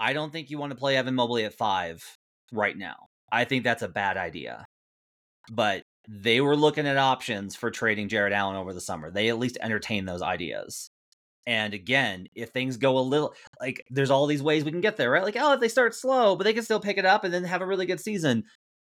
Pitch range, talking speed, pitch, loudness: 110-165 Hz, 240 wpm, 130 Hz, -26 LUFS